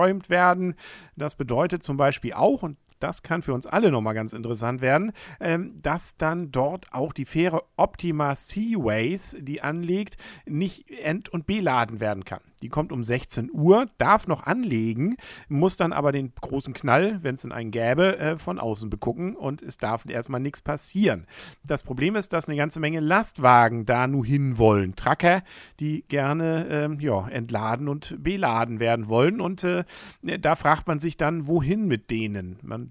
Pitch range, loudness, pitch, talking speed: 125-175 Hz, -25 LUFS, 150 Hz, 165 wpm